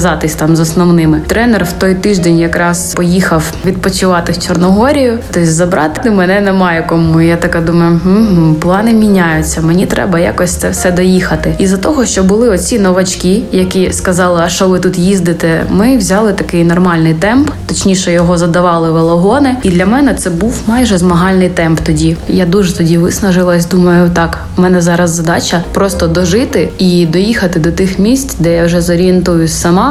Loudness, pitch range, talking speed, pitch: -9 LUFS, 170-195 Hz, 165 wpm, 180 Hz